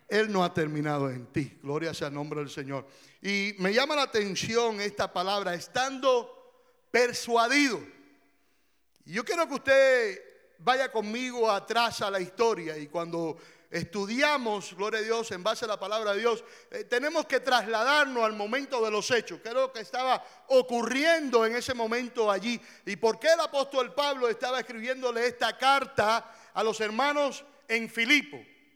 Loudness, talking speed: -28 LUFS, 165 wpm